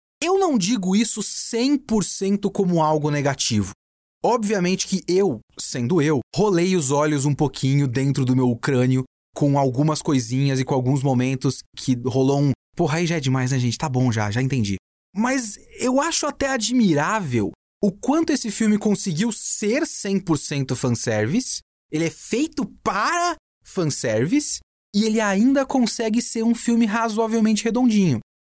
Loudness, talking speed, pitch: -20 LUFS, 150 wpm, 175 Hz